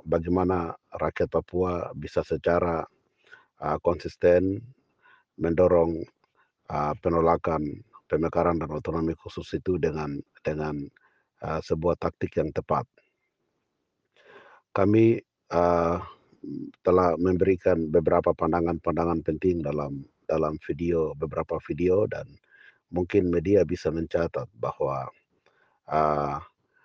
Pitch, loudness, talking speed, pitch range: 85 Hz, -26 LUFS, 85 wpm, 80-90 Hz